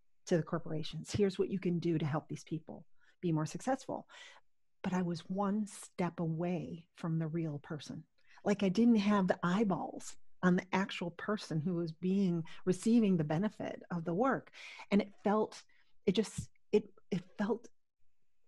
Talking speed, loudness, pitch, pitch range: 170 wpm, -35 LUFS, 180 Hz, 170-205 Hz